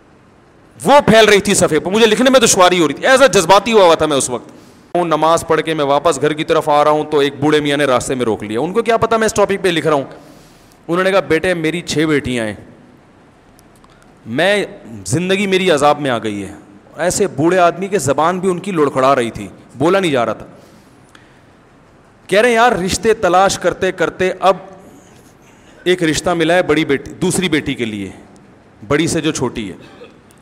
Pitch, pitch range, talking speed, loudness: 160 Hz, 140-190 Hz, 210 wpm, -14 LUFS